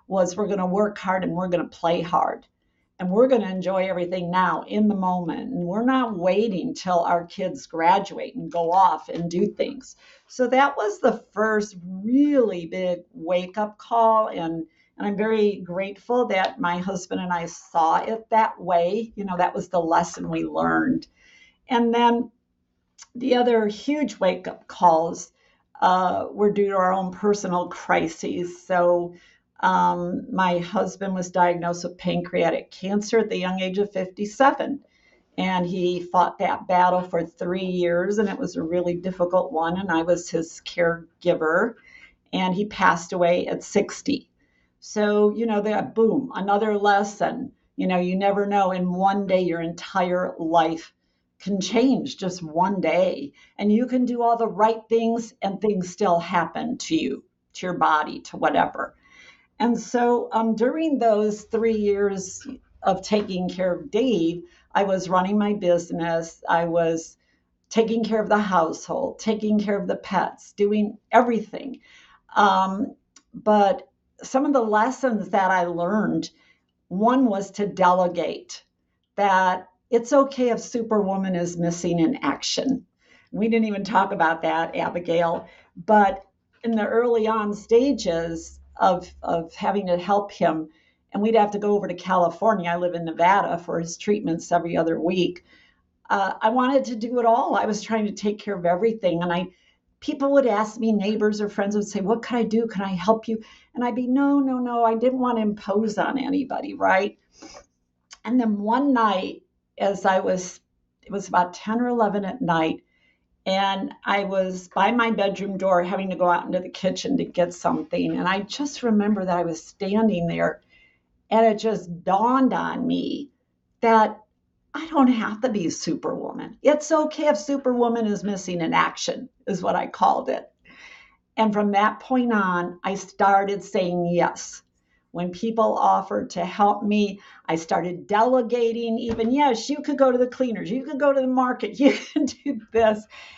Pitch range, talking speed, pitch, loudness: 180-230 Hz, 170 wpm, 205 Hz, -23 LUFS